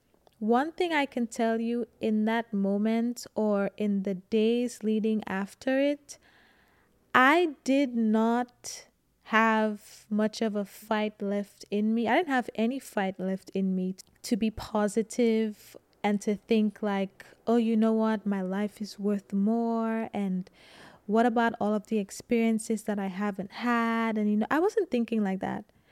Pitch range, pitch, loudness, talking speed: 205-235 Hz, 220 Hz, -28 LUFS, 165 wpm